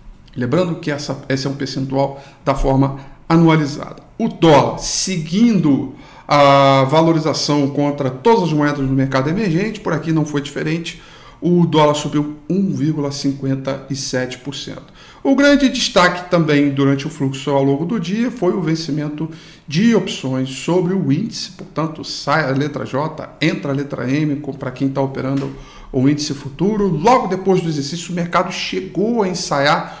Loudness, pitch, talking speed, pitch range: -17 LUFS, 150 Hz, 150 wpm, 140-175 Hz